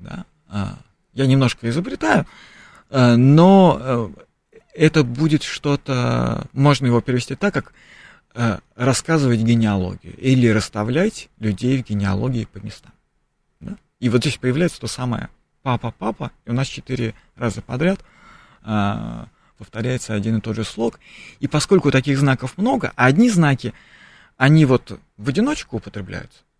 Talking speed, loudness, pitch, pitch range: 125 wpm, -19 LUFS, 125 Hz, 110-145 Hz